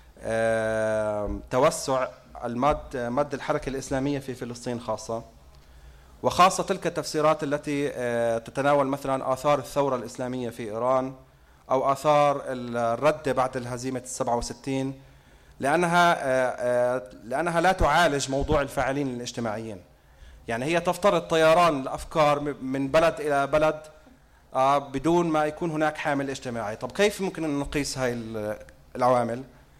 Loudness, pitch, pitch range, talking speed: -25 LUFS, 135 Hz, 120-150 Hz, 120 wpm